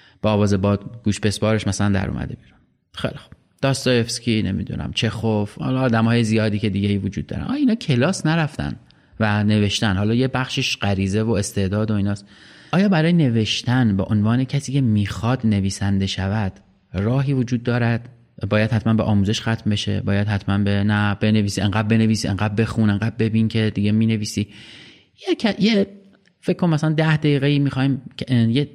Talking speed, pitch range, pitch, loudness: 165 wpm, 100-130 Hz, 110 Hz, -20 LUFS